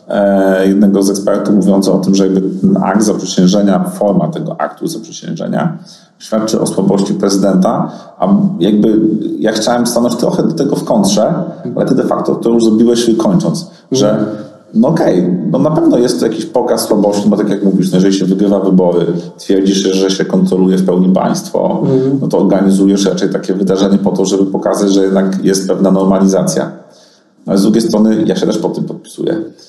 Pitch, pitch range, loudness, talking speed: 100 Hz, 95-115 Hz, -12 LUFS, 185 wpm